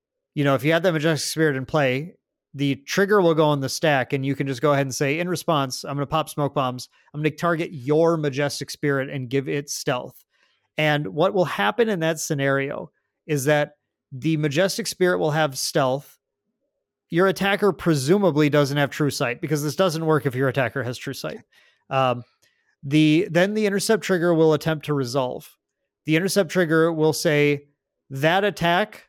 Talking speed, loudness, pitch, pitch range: 190 wpm, -22 LUFS, 155 Hz, 140-170 Hz